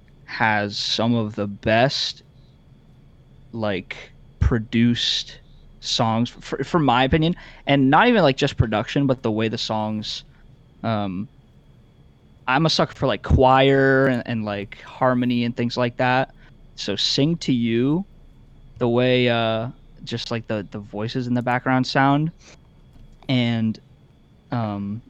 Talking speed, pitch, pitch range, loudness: 135 wpm, 125 Hz, 110-135 Hz, -21 LUFS